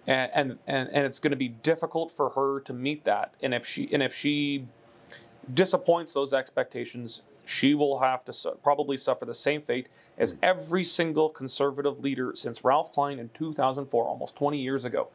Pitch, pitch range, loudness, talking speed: 140 Hz, 130-155 Hz, -28 LUFS, 180 wpm